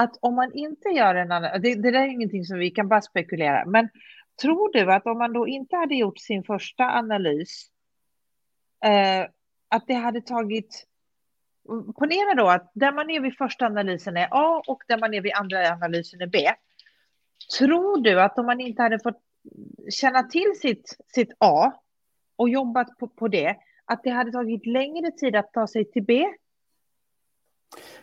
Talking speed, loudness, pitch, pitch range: 180 wpm, -23 LUFS, 235 Hz, 205-260 Hz